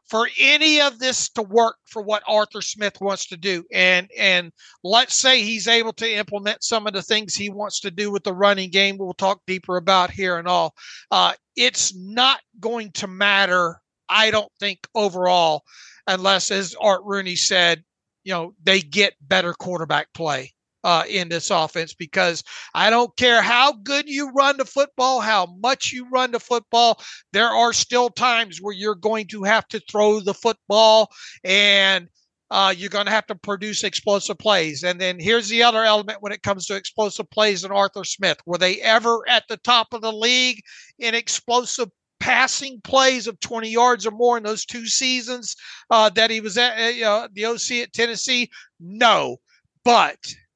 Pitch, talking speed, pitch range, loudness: 210 Hz, 185 wpm, 190-235 Hz, -19 LUFS